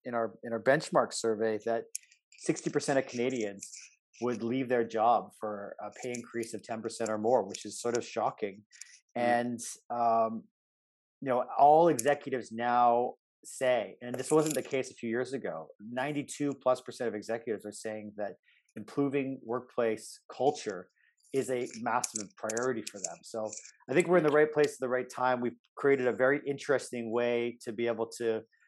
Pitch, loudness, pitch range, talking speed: 120 Hz, -31 LUFS, 115-135 Hz, 180 wpm